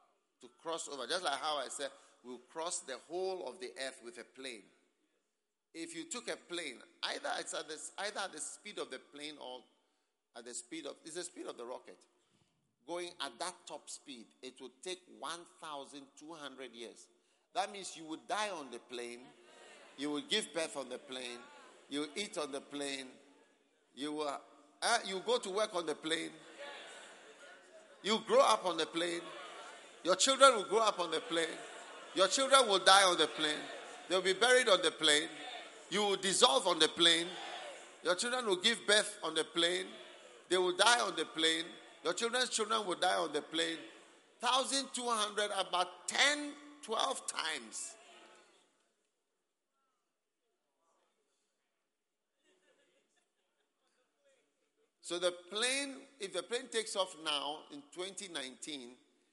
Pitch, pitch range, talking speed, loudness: 175 Hz, 150-220 Hz, 160 wpm, -34 LUFS